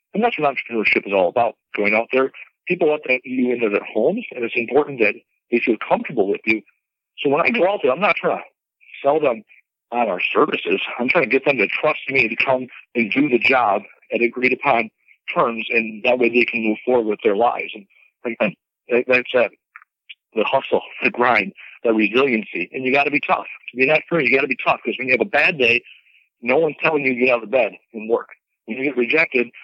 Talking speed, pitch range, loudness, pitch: 235 wpm, 115-140 Hz, -19 LUFS, 125 Hz